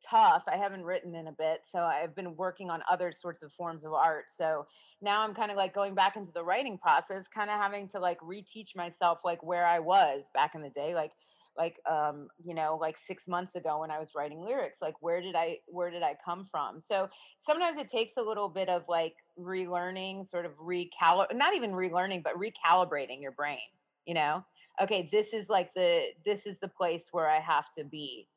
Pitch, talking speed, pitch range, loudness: 175 Hz, 220 wpm, 160-195 Hz, -32 LUFS